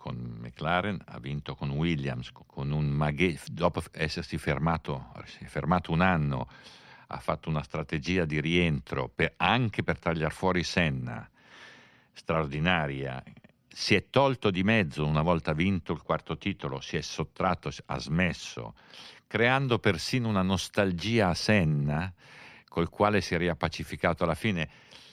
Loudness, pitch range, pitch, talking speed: -29 LUFS, 75-95 Hz, 85 Hz, 135 wpm